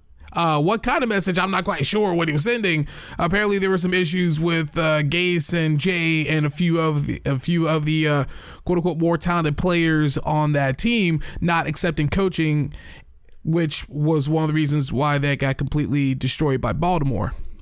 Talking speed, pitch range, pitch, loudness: 195 wpm, 150-175 Hz, 160 Hz, -20 LUFS